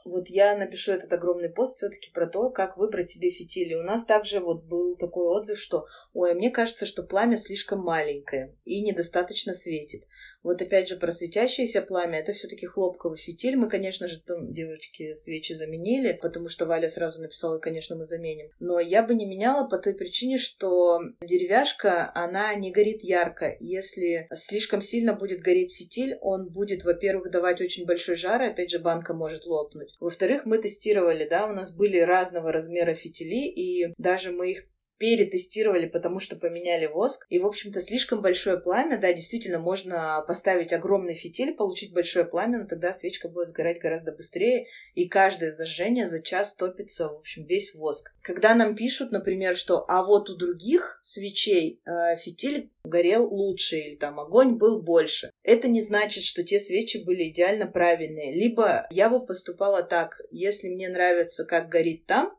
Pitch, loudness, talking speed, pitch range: 185 Hz, -26 LUFS, 175 wpm, 170-210 Hz